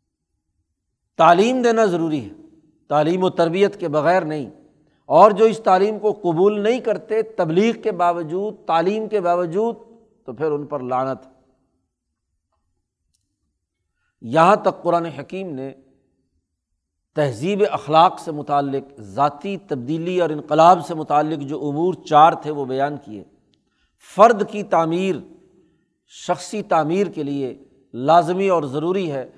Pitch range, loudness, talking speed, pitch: 135-190 Hz, -19 LUFS, 125 wpm, 165 Hz